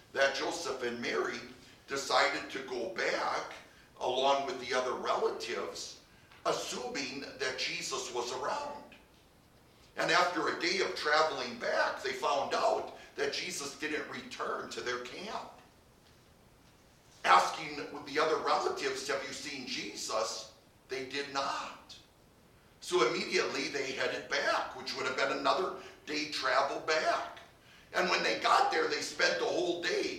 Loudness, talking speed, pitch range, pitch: -33 LUFS, 135 wpm, 120-180 Hz, 140 Hz